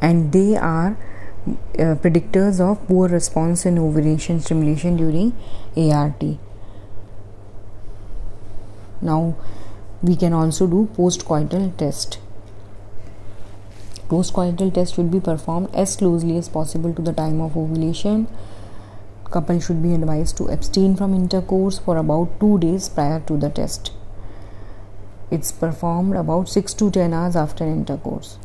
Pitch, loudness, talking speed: 160 Hz, -20 LUFS, 130 wpm